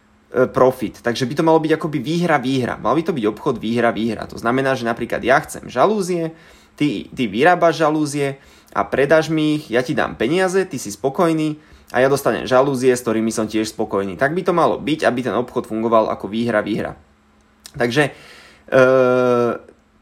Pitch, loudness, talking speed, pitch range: 130 Hz, -18 LUFS, 185 wpm, 115-150 Hz